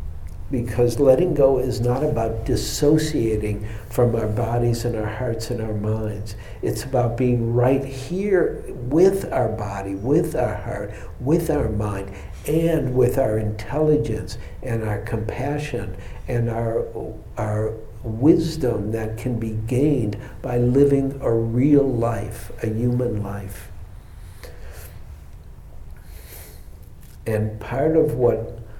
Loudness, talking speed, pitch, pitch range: -22 LUFS, 120 wpm, 115 Hz, 105-130 Hz